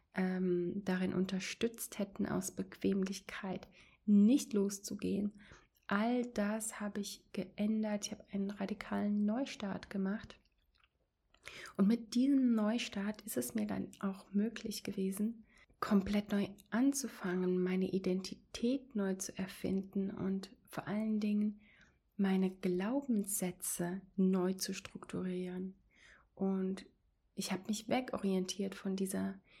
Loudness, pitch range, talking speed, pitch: -37 LUFS, 190-215 Hz, 105 wpm, 200 Hz